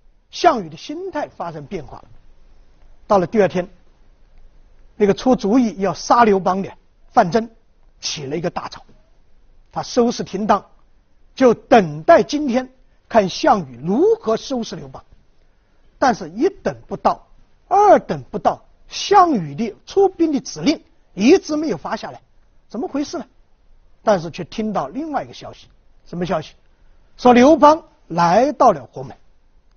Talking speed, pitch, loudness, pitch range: 210 characters per minute, 235 Hz, -18 LUFS, 195-300 Hz